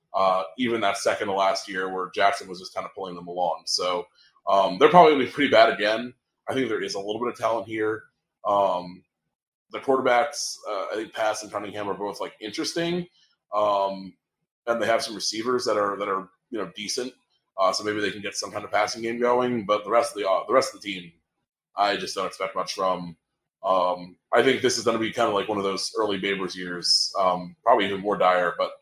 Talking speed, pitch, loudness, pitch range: 235 wpm, 105 Hz, -24 LUFS, 95-115 Hz